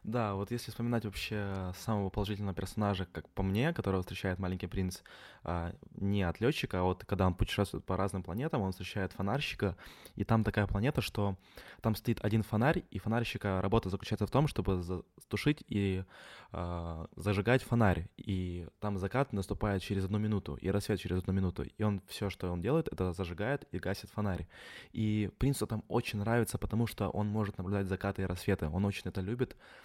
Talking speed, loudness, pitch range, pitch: 180 wpm, -35 LUFS, 95-110 Hz, 100 Hz